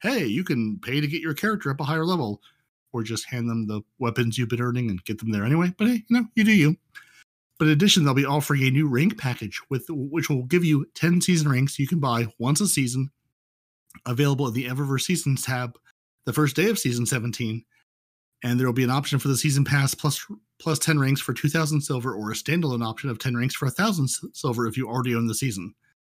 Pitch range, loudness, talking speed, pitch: 120-155 Hz, -24 LUFS, 235 wpm, 135 Hz